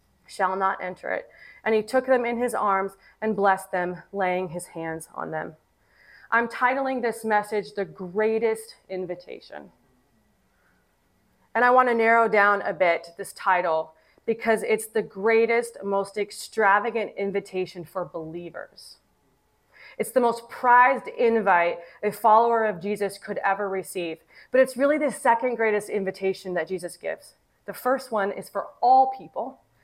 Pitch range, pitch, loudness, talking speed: 185-230 Hz, 205 Hz, -24 LUFS, 150 wpm